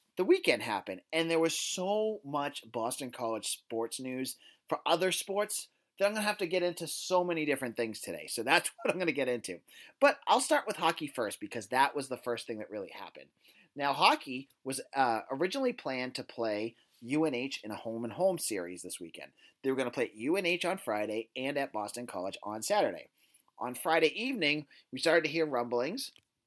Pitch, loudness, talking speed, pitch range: 145 Hz, -32 LUFS, 200 wpm, 120-185 Hz